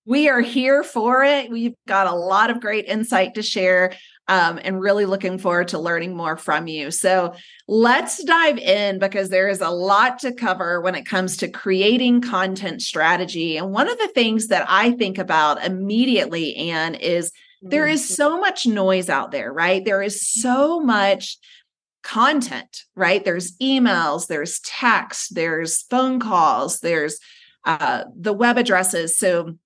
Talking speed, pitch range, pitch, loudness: 165 wpm, 185-245 Hz, 195 Hz, -19 LUFS